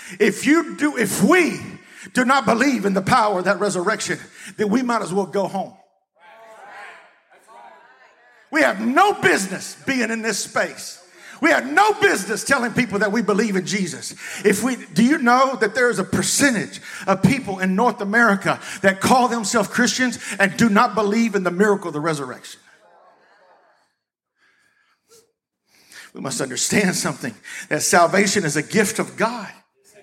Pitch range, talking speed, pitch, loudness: 195-250 Hz, 160 wpm, 220 Hz, -19 LUFS